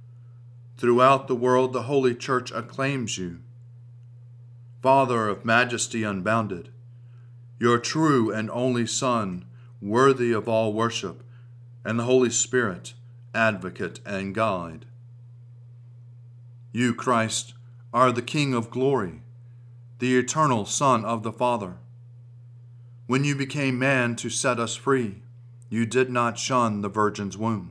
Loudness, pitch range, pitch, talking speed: -24 LUFS, 115-125 Hz, 120 Hz, 120 wpm